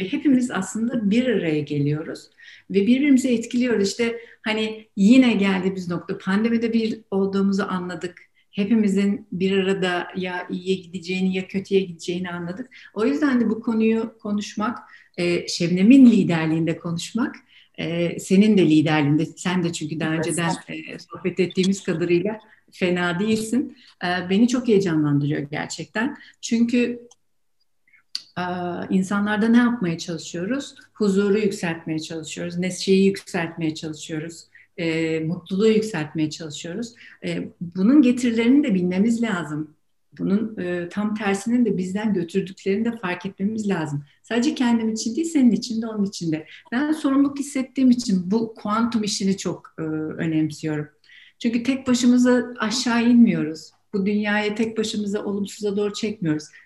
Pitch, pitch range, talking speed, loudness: 200 Hz, 175-230 Hz, 125 wpm, -22 LUFS